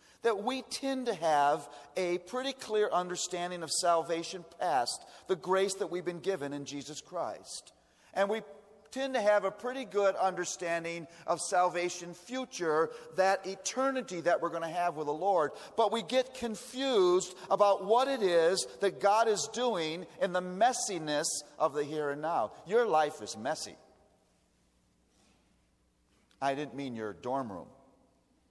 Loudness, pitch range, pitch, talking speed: -32 LUFS, 155-210 Hz, 180 Hz, 155 wpm